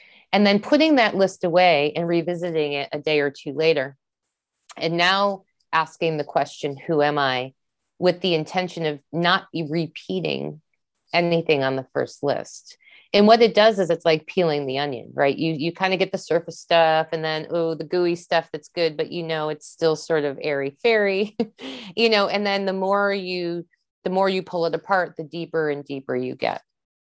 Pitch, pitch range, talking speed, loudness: 165 Hz, 155-190 Hz, 195 wpm, -22 LUFS